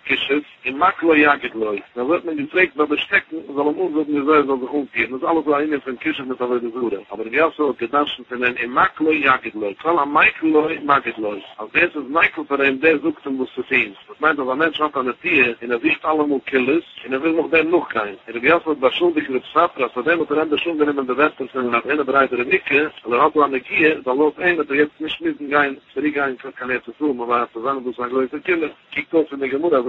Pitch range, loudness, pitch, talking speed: 130-155 Hz, -19 LUFS, 145 Hz, 250 wpm